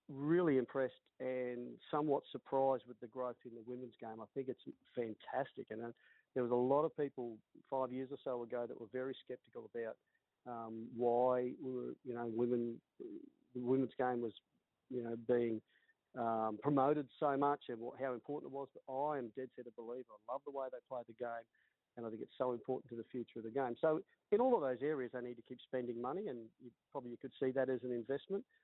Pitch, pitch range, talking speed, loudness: 125 Hz, 120-135 Hz, 220 wpm, -41 LUFS